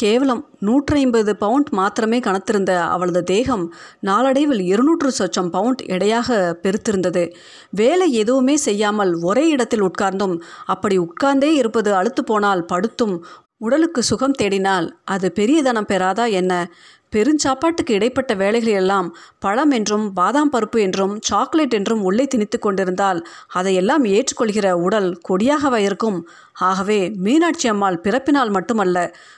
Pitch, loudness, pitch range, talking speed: 210 Hz, -18 LUFS, 190-250 Hz, 115 wpm